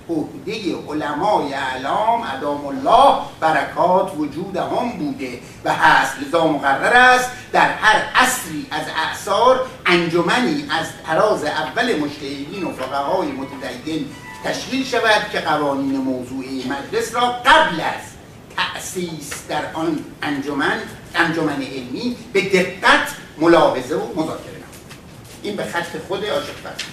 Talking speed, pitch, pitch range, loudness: 120 wpm, 160 Hz, 140-215 Hz, -18 LUFS